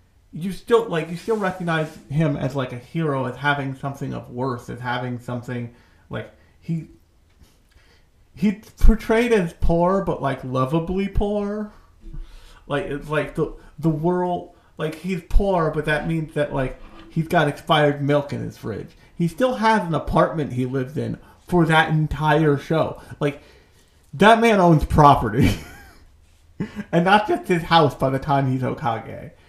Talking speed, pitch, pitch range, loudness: 155 wpm, 150 Hz, 130-175 Hz, -21 LUFS